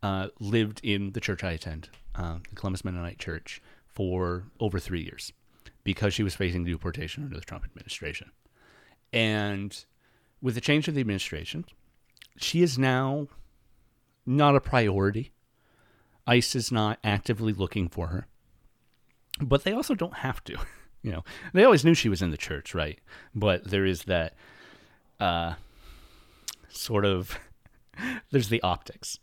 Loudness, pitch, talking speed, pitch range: -28 LUFS, 100 Hz, 150 wpm, 90-120 Hz